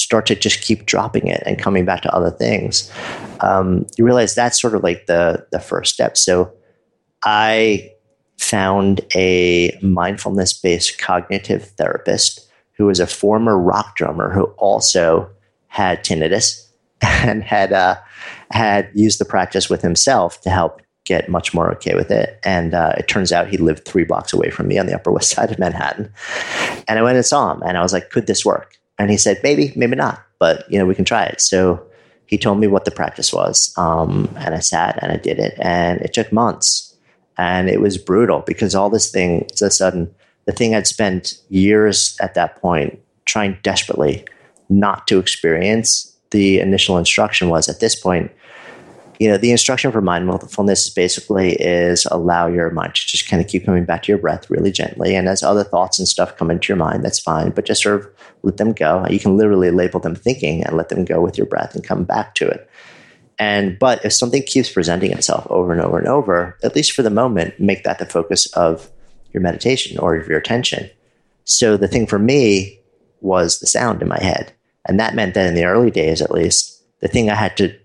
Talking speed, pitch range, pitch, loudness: 205 wpm, 90-105 Hz, 95 Hz, -16 LUFS